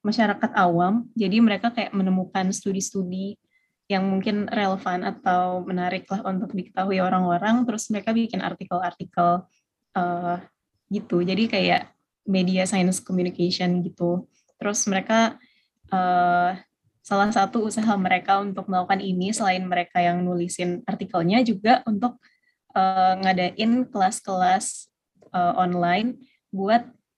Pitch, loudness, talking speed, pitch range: 190 Hz, -23 LUFS, 115 wpm, 180-215 Hz